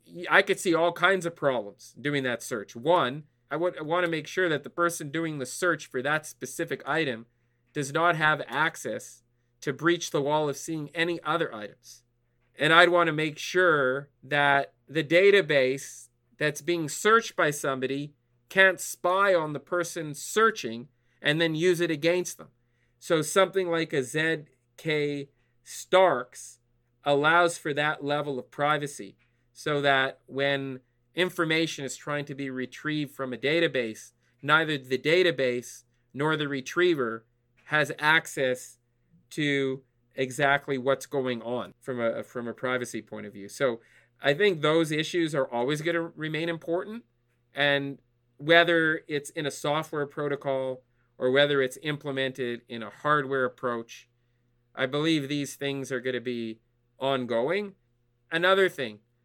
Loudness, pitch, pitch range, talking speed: -26 LUFS, 140 Hz, 125-160 Hz, 150 wpm